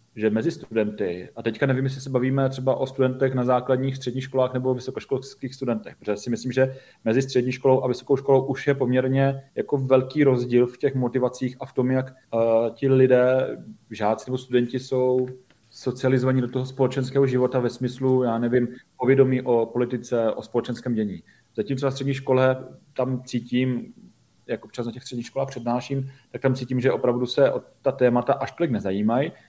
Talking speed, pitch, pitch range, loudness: 180 wpm, 130 Hz, 125-135 Hz, -24 LUFS